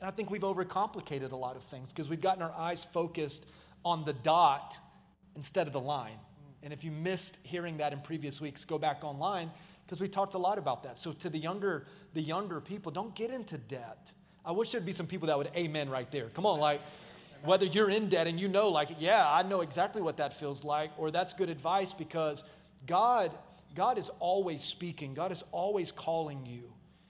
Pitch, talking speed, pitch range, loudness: 165 Hz, 215 wpm, 150-185 Hz, -33 LUFS